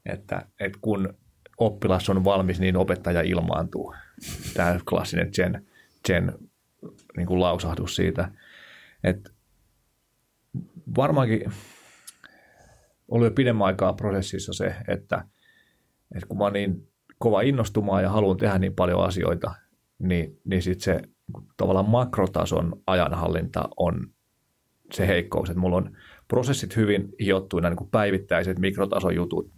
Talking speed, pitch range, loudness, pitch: 120 wpm, 90-105 Hz, -25 LUFS, 95 Hz